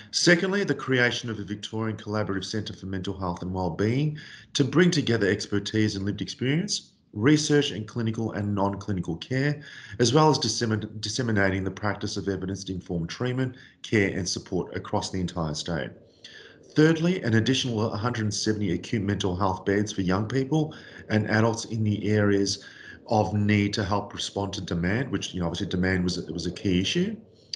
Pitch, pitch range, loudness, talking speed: 105 Hz, 95-120 Hz, -26 LUFS, 170 wpm